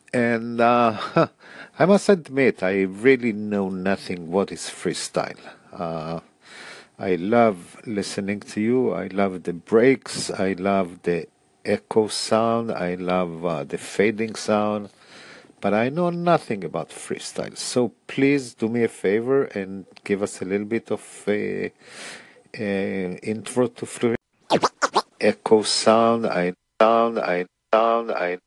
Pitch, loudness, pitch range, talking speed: 105 Hz, -23 LUFS, 95-115 Hz, 135 wpm